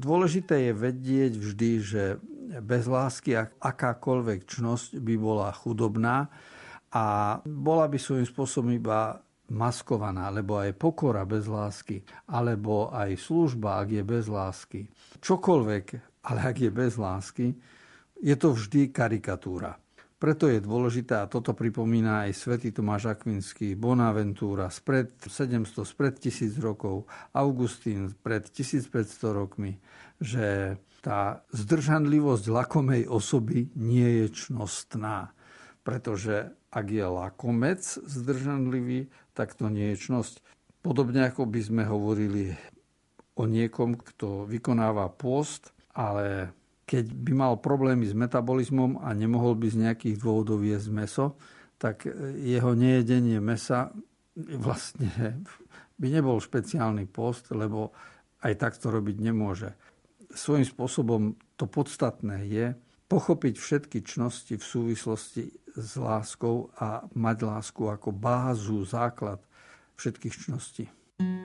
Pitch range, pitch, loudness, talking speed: 105-130 Hz, 115 Hz, -29 LUFS, 115 wpm